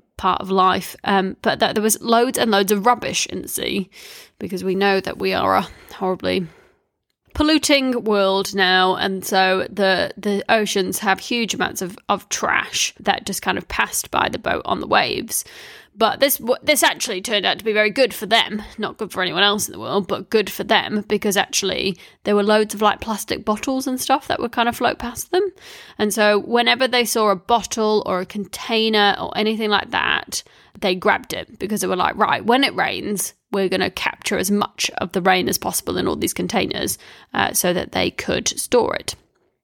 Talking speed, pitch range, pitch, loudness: 210 wpm, 195-235 Hz, 210 Hz, -19 LUFS